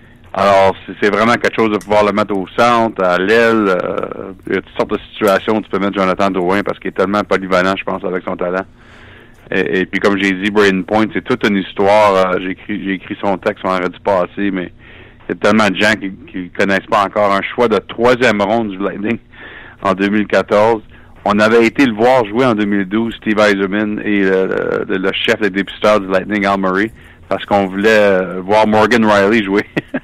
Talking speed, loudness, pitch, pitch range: 220 wpm, -14 LUFS, 100 Hz, 95-110 Hz